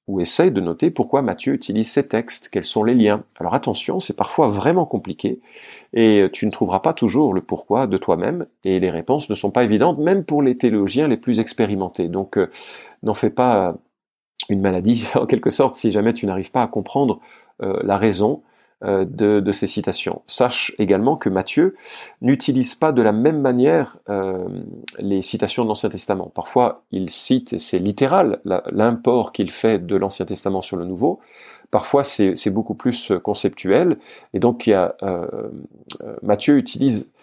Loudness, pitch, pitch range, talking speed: -19 LUFS, 110 Hz, 100-125 Hz, 180 wpm